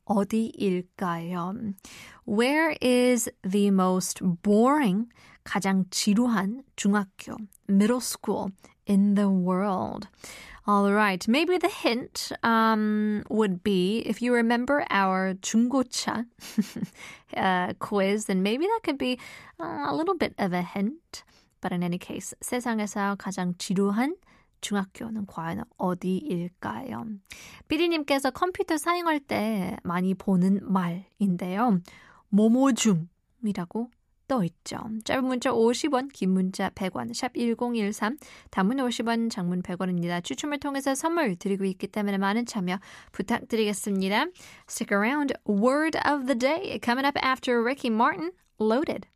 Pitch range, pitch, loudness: 195-250 Hz, 215 Hz, -26 LUFS